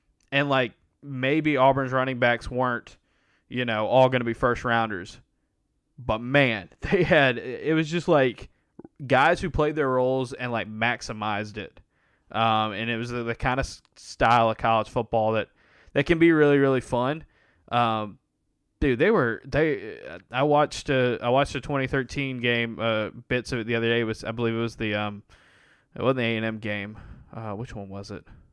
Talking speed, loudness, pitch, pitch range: 190 wpm, -24 LUFS, 120 Hz, 110-130 Hz